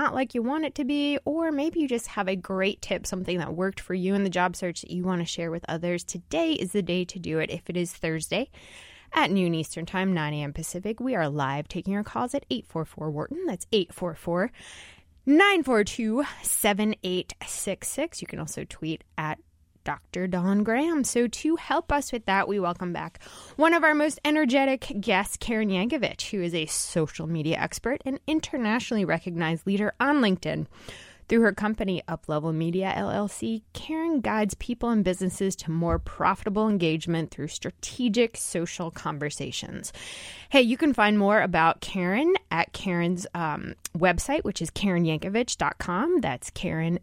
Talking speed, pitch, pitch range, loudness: 165 wpm, 190 Hz, 170-245 Hz, -27 LUFS